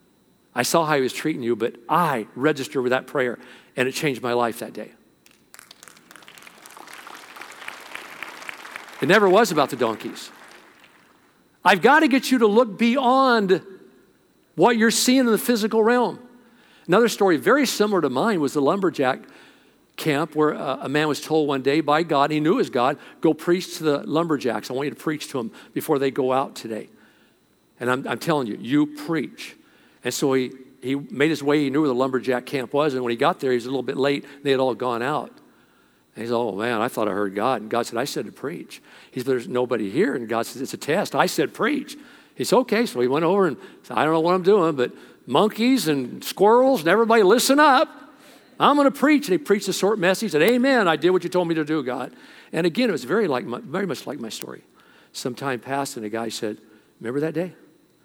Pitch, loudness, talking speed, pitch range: 150 Hz, -21 LUFS, 225 wpm, 130-215 Hz